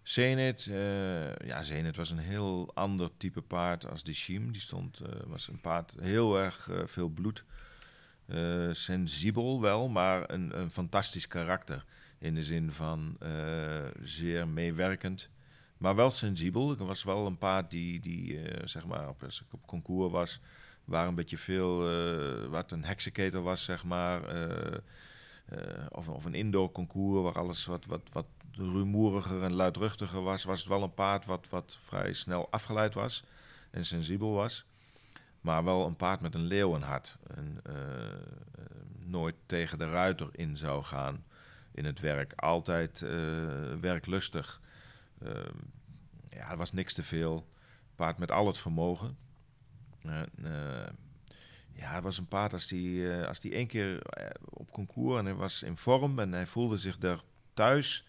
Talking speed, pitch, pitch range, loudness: 165 wpm, 95 Hz, 85-105 Hz, -34 LUFS